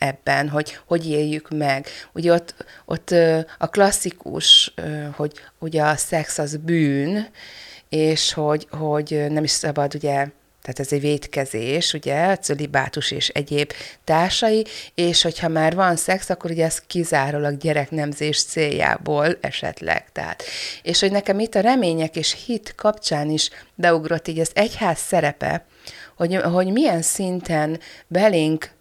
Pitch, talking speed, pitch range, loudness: 160 Hz, 135 wpm, 150-175 Hz, -20 LUFS